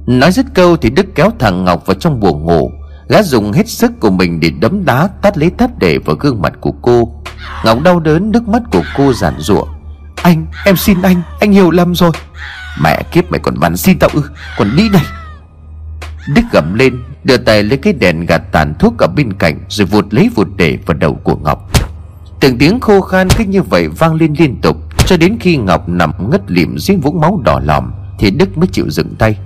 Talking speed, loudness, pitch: 225 wpm, -11 LUFS, 120 Hz